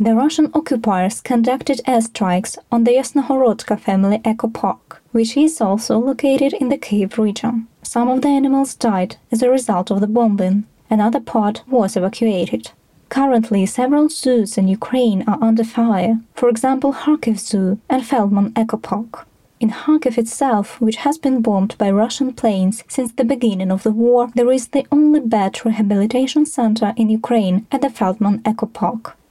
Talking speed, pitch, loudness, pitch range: 160 wpm, 230 Hz, -17 LUFS, 210-260 Hz